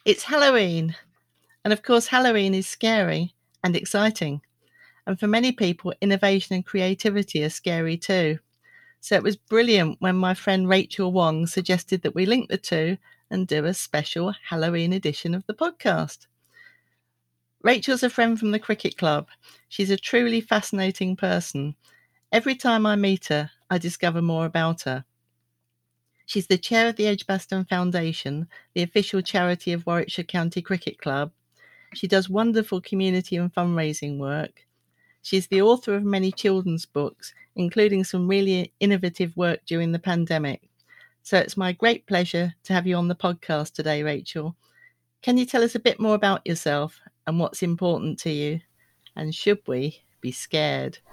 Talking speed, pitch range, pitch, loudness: 160 wpm, 165-205 Hz, 185 Hz, -24 LUFS